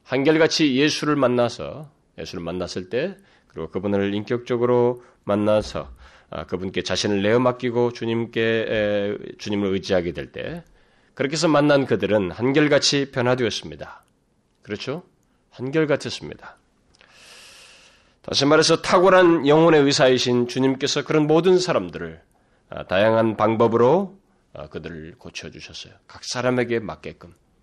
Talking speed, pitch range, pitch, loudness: 305 characters per minute, 105-150 Hz, 125 Hz, -20 LUFS